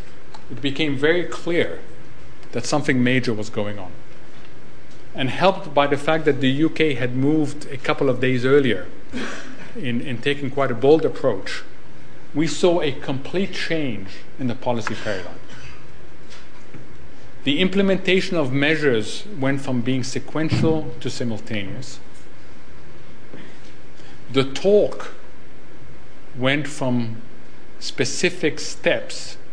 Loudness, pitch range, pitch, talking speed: -22 LUFS, 125-155 Hz, 135 Hz, 115 wpm